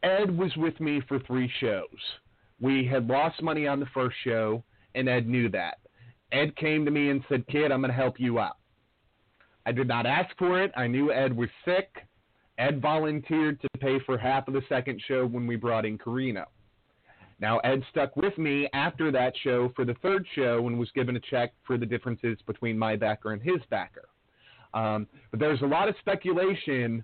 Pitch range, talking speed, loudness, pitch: 120-150 Hz, 200 wpm, -28 LUFS, 130 Hz